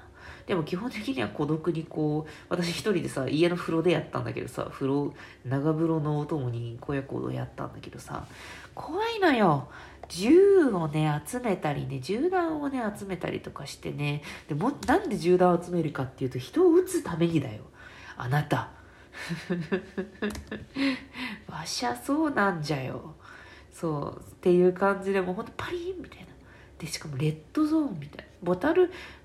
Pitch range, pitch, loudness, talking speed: 150-215 Hz, 175 Hz, -28 LUFS, 320 characters per minute